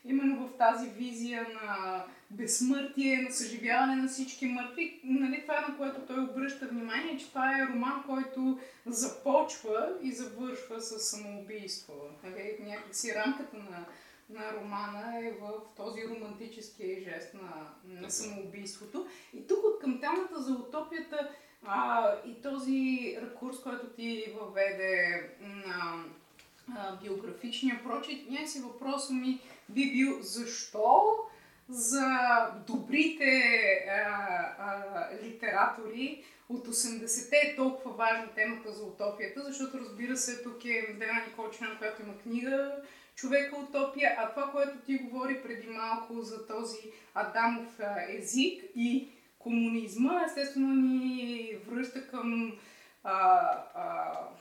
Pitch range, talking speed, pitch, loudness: 215-270 Hz, 120 wpm, 240 Hz, -33 LUFS